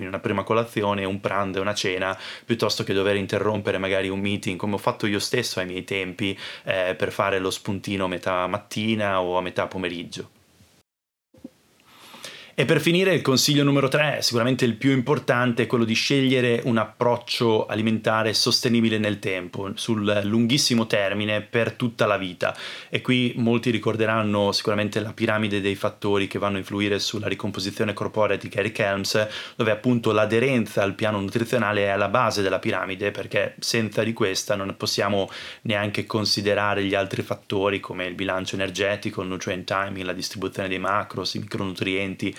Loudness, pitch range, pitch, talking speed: -23 LUFS, 100-115 Hz, 105 Hz, 165 wpm